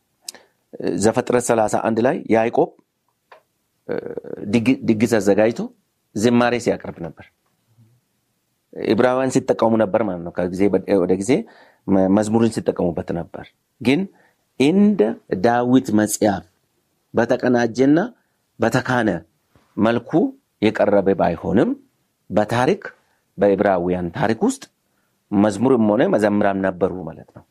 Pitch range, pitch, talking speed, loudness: 100-125 Hz, 115 Hz, 80 wpm, -19 LUFS